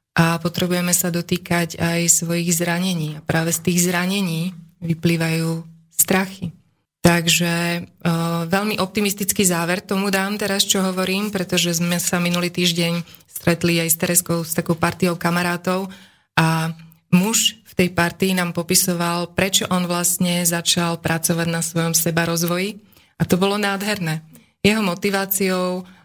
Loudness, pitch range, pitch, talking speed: -19 LUFS, 170-185 Hz, 175 Hz, 135 wpm